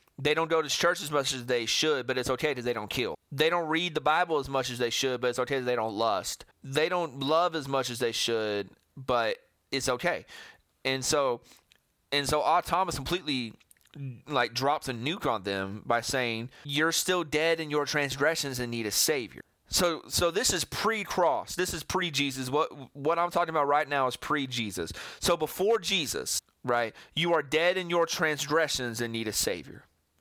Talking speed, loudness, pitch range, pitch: 200 wpm, -28 LUFS, 125-160 Hz, 145 Hz